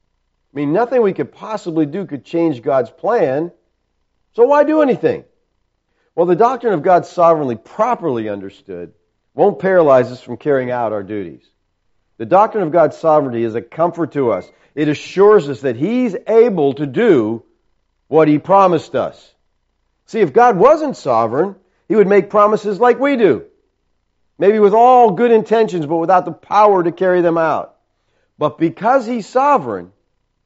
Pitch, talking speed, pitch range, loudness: 170 Hz, 160 wpm, 140-220 Hz, -14 LUFS